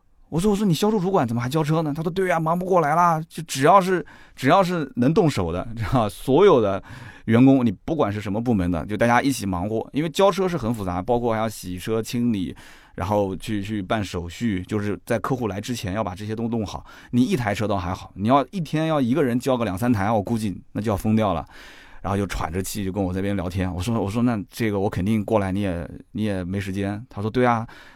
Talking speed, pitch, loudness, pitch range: 345 characters per minute, 110 Hz, -22 LUFS, 100-130 Hz